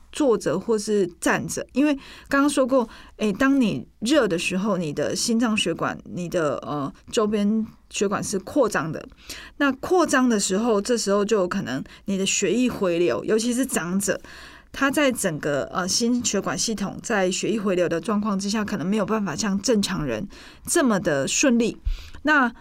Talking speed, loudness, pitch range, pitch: 255 characters per minute, -23 LUFS, 190-245 Hz, 215 Hz